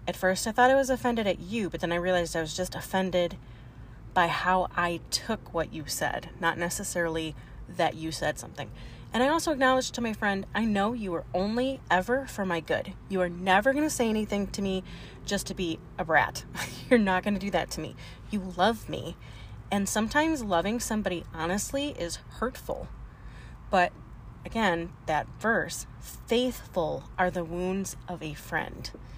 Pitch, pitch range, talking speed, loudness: 185 Hz, 165-220 Hz, 185 wpm, -29 LUFS